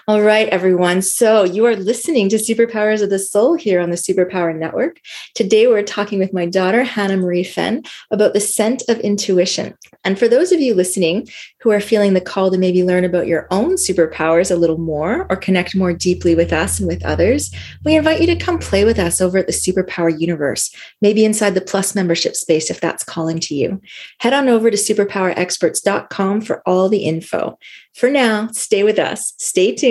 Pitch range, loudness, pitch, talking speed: 180-220 Hz, -16 LUFS, 195 Hz, 205 wpm